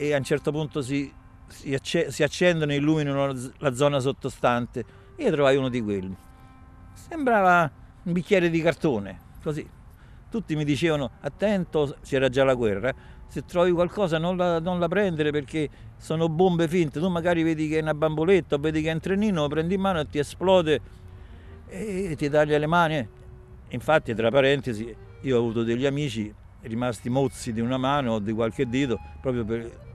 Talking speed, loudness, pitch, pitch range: 175 wpm, -25 LUFS, 145 Hz, 115-165 Hz